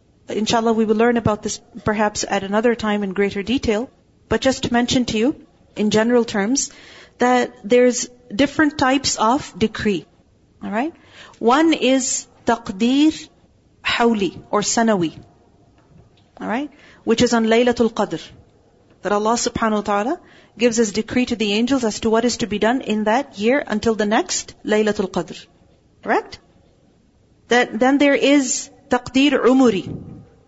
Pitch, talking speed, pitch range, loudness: 230 Hz, 150 wpm, 210-250 Hz, -19 LUFS